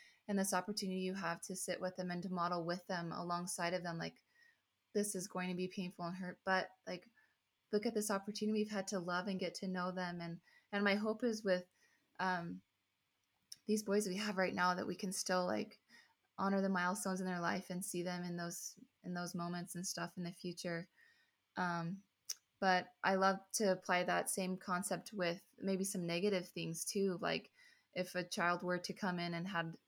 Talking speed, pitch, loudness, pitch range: 205 wpm, 185 Hz, -40 LUFS, 175-195 Hz